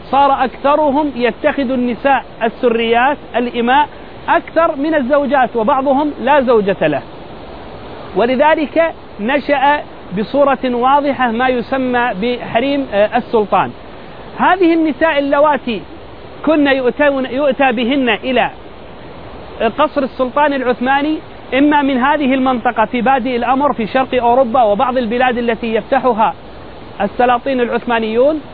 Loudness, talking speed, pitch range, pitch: -14 LUFS, 100 wpm, 240-285 Hz, 265 Hz